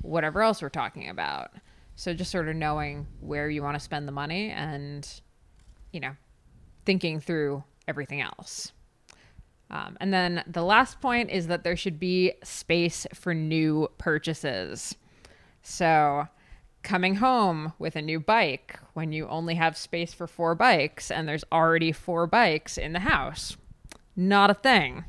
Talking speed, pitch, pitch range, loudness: 155 wpm, 165 Hz, 150-185 Hz, -27 LUFS